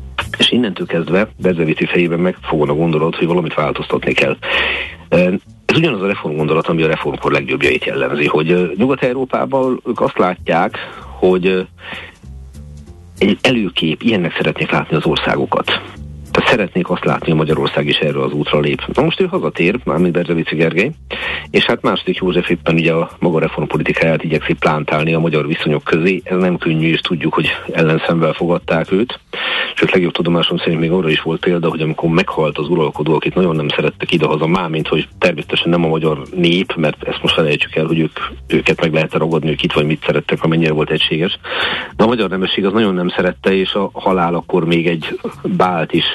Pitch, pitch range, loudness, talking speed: 80 Hz, 80-90 Hz, -15 LUFS, 180 wpm